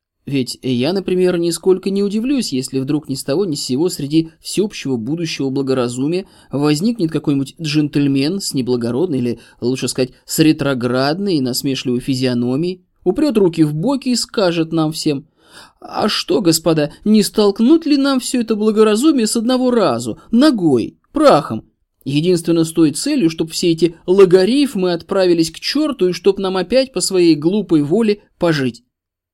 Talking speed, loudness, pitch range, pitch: 150 wpm, -16 LUFS, 135-200 Hz, 165 Hz